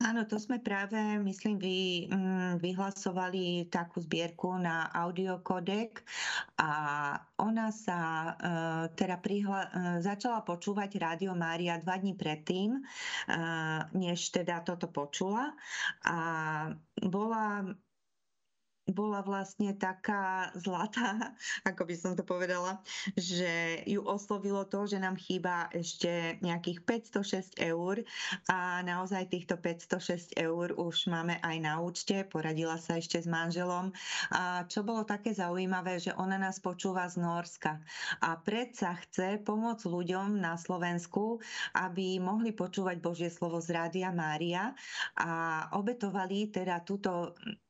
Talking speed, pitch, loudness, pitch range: 120 wpm, 185 Hz, -35 LUFS, 170-200 Hz